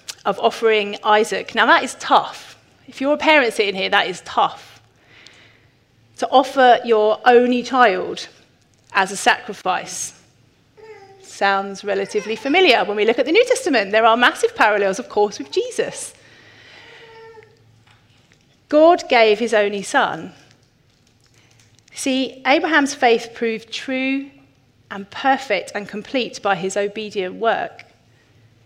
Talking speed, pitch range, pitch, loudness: 125 wpm, 195-275 Hz, 225 Hz, -17 LUFS